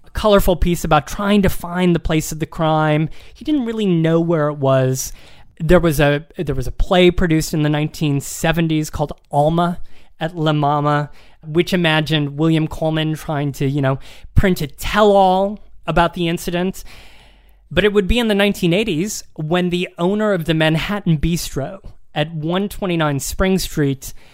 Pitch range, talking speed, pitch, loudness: 150-180 Hz, 170 wpm, 160 Hz, -18 LUFS